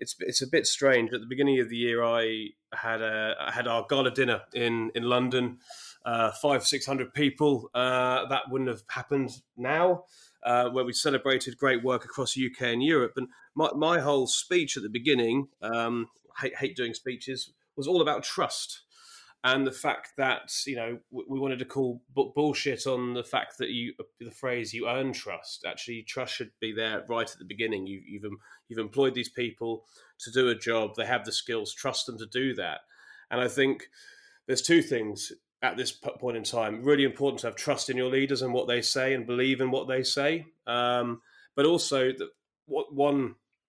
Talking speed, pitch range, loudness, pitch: 200 wpm, 120-135 Hz, -28 LUFS, 130 Hz